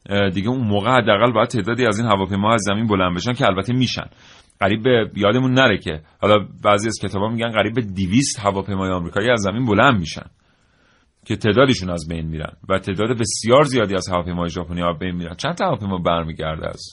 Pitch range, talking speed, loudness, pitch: 90-120 Hz, 200 wpm, -19 LUFS, 100 Hz